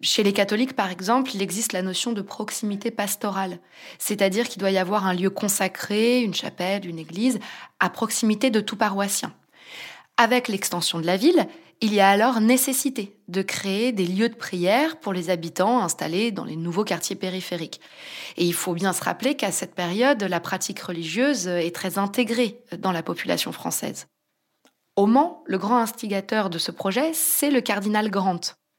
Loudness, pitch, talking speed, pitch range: -23 LUFS, 205 Hz, 175 wpm, 185-235 Hz